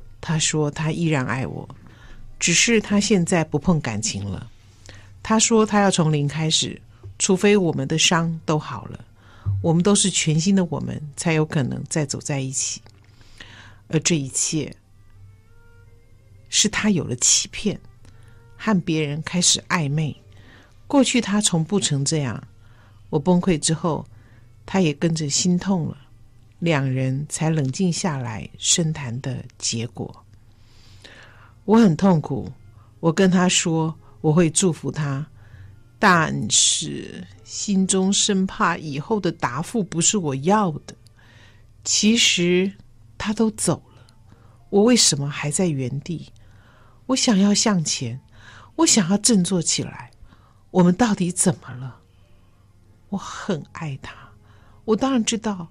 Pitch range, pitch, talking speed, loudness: 110-180 Hz, 145 Hz, 185 characters per minute, -20 LUFS